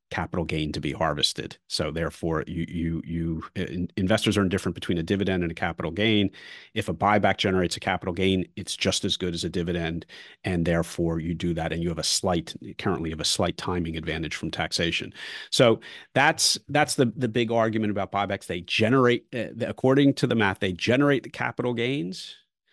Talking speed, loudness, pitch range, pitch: 200 wpm, -25 LUFS, 85-110 Hz, 95 Hz